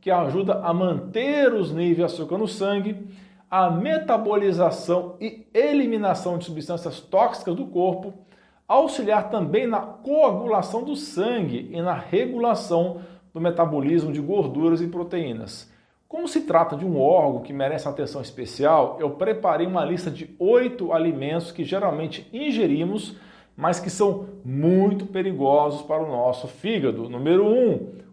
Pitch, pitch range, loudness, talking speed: 180 Hz, 160-210 Hz, -23 LUFS, 140 wpm